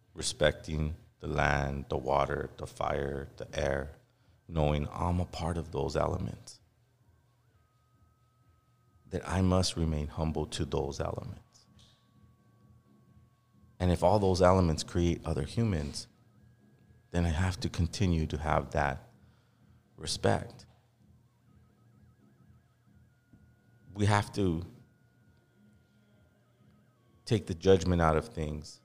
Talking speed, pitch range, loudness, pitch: 105 wpm, 80-115 Hz, -31 LUFS, 95 Hz